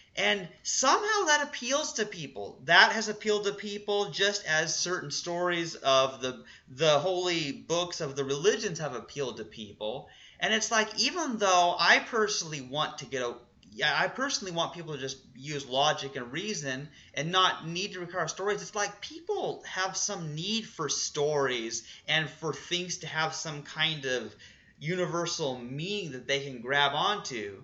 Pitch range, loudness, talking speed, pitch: 140-205 Hz, -29 LUFS, 170 wpm, 170 Hz